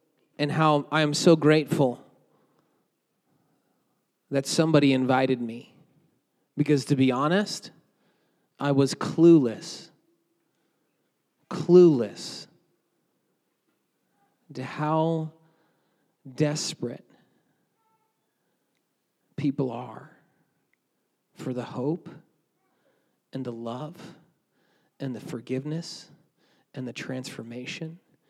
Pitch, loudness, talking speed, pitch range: 150 Hz, -25 LUFS, 75 wpm, 130-165 Hz